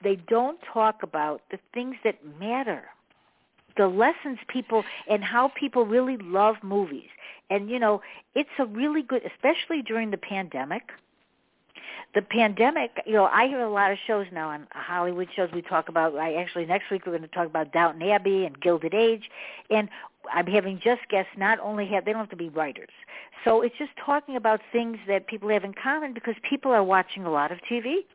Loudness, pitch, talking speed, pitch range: -26 LUFS, 210 Hz, 195 wpm, 190-240 Hz